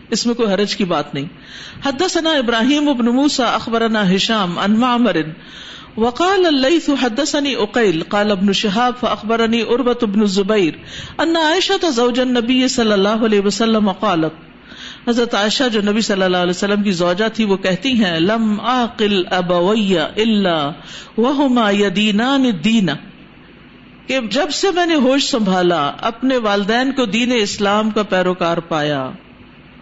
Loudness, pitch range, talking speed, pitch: -16 LUFS, 200-255 Hz, 100 wpm, 225 Hz